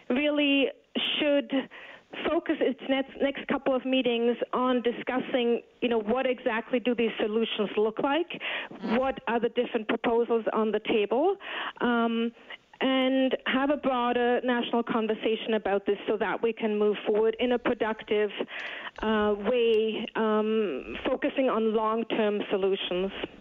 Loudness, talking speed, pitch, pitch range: -27 LUFS, 135 wpm, 240 Hz, 220-260 Hz